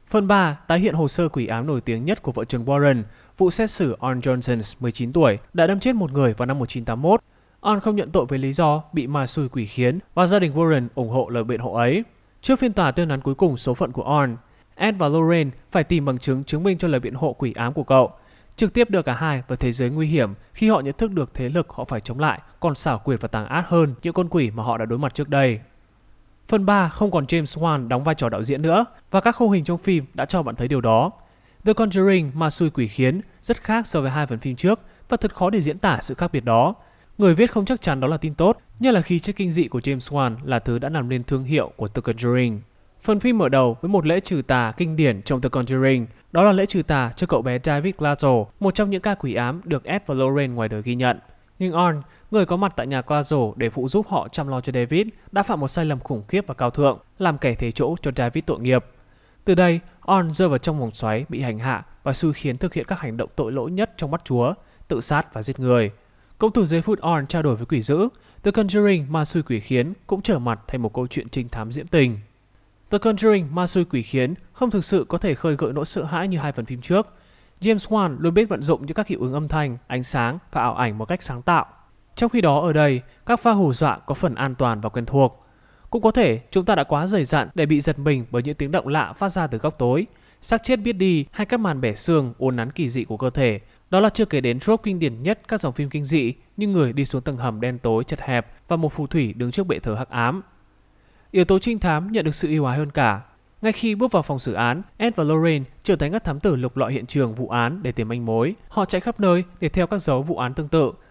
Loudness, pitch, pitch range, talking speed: -21 LUFS, 150 Hz, 125-185 Hz, 270 wpm